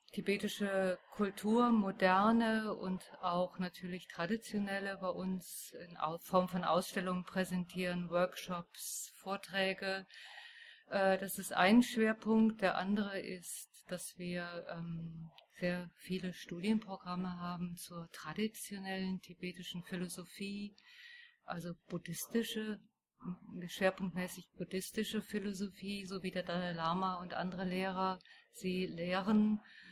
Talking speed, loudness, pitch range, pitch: 95 wpm, -38 LUFS, 180-205 Hz, 190 Hz